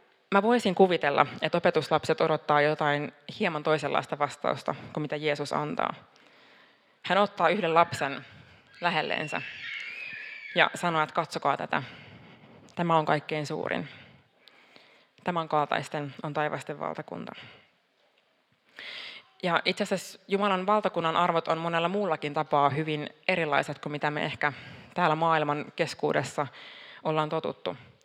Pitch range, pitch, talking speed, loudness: 150-175 Hz, 155 Hz, 115 wpm, -28 LUFS